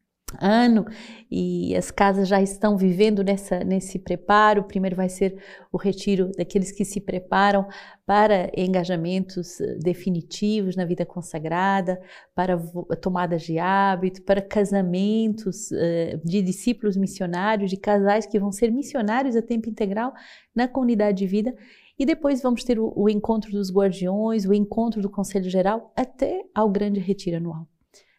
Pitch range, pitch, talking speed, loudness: 185-215 Hz, 200 Hz, 145 wpm, -23 LUFS